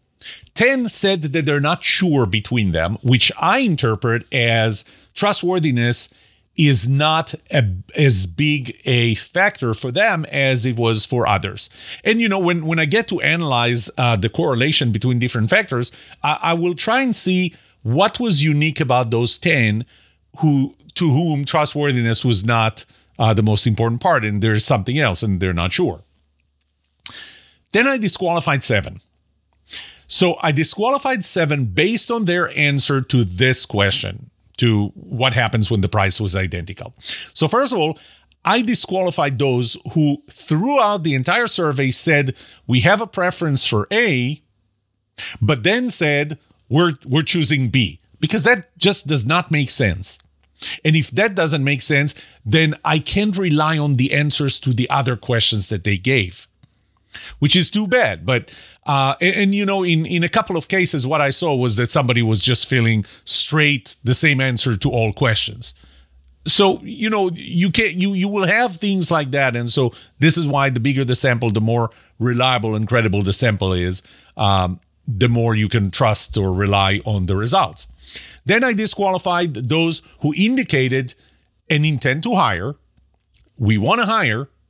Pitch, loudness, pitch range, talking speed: 130 Hz, -17 LUFS, 110-165 Hz, 165 wpm